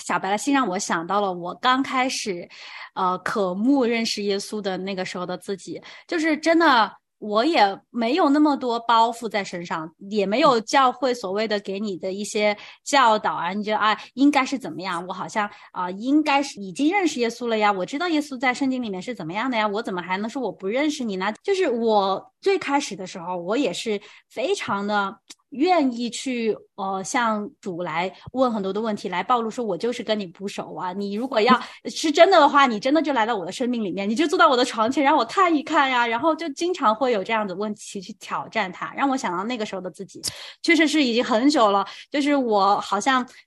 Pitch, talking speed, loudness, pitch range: 220 Hz, 320 characters per minute, -22 LUFS, 200-270 Hz